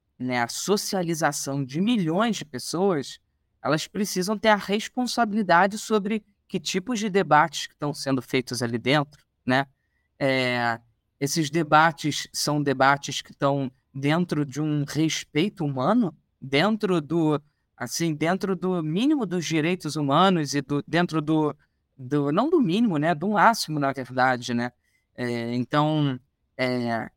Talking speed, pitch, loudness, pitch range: 135 wpm, 150 Hz, -24 LUFS, 135-185 Hz